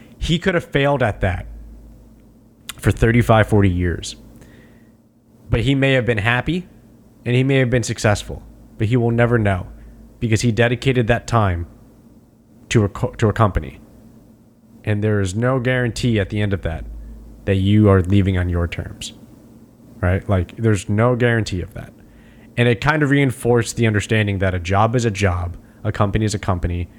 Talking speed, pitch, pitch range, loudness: 175 wpm, 115 Hz, 100-120 Hz, -18 LUFS